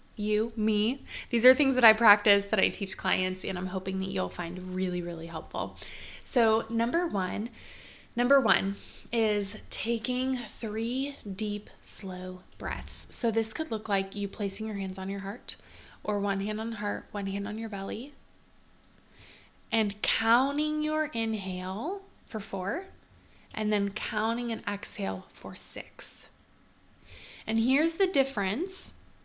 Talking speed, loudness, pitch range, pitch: 145 wpm, -28 LUFS, 190-235 Hz, 210 Hz